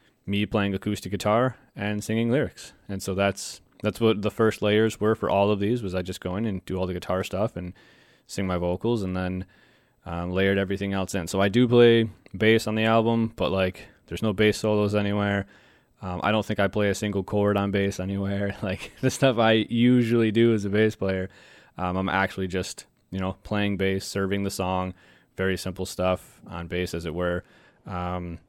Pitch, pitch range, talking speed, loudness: 100 Hz, 95-110 Hz, 210 wpm, -25 LUFS